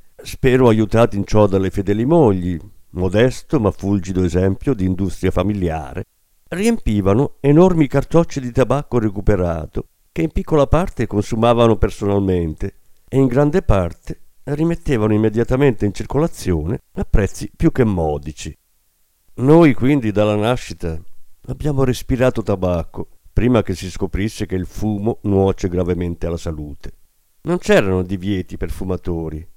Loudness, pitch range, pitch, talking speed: -18 LUFS, 90-130 Hz, 105 Hz, 125 wpm